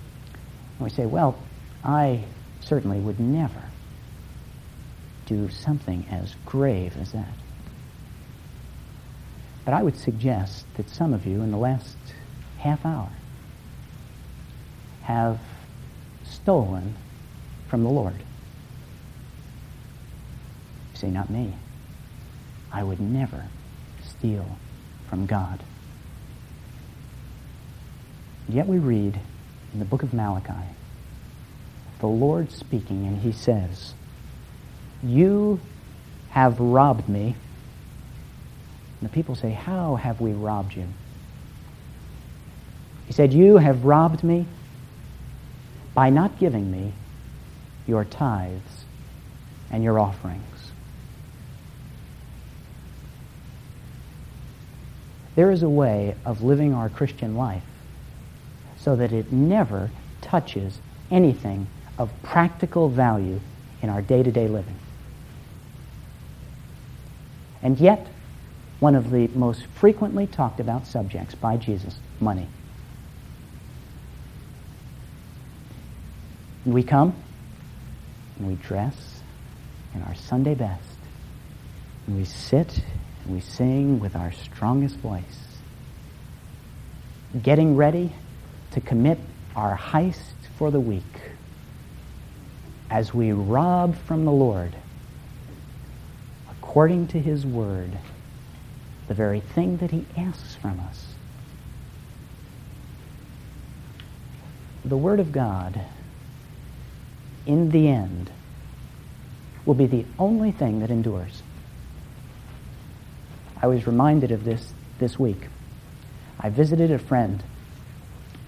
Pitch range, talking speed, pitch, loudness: 100-140 Hz, 100 wpm, 120 Hz, -23 LUFS